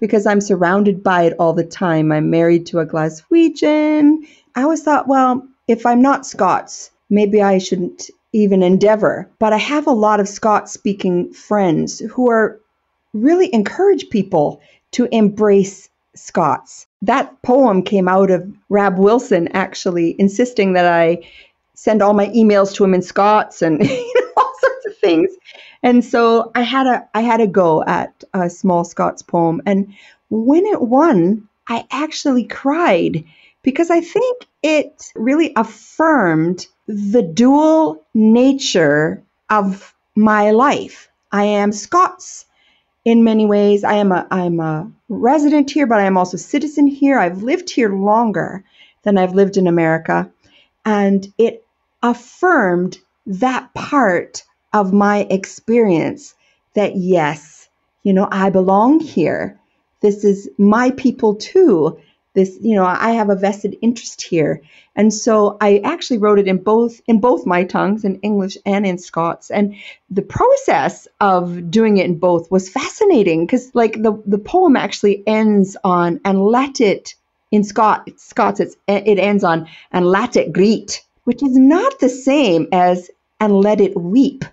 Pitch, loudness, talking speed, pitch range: 210 Hz, -15 LUFS, 155 wpm, 190-255 Hz